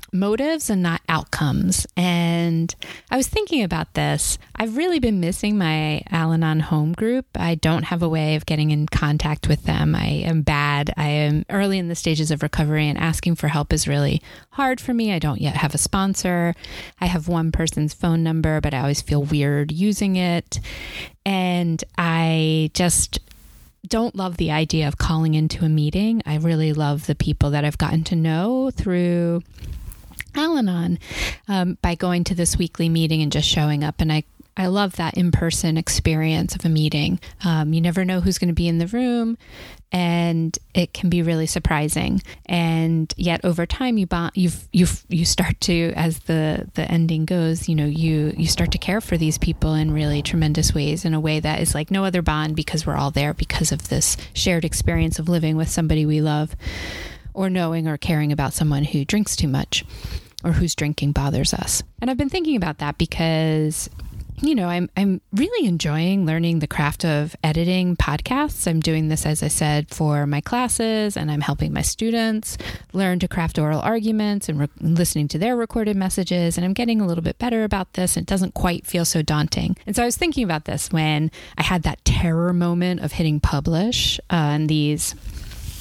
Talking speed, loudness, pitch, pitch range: 195 wpm, -21 LUFS, 165 Hz, 155-185 Hz